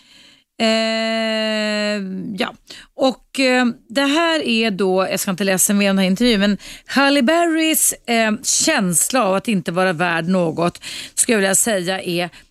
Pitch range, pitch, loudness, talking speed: 190-255 Hz, 215 Hz, -17 LUFS, 155 wpm